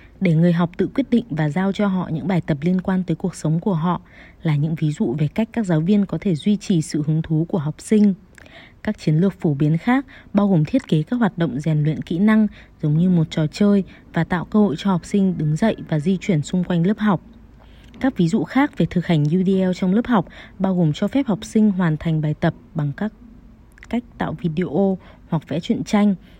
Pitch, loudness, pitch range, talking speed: 180 Hz, -20 LUFS, 160-205 Hz, 245 wpm